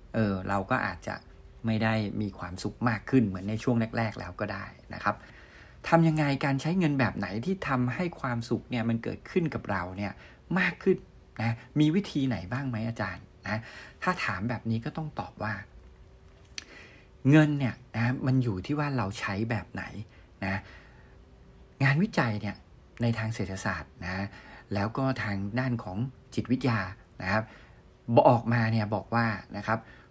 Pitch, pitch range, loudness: 115 Hz, 100-130 Hz, -29 LUFS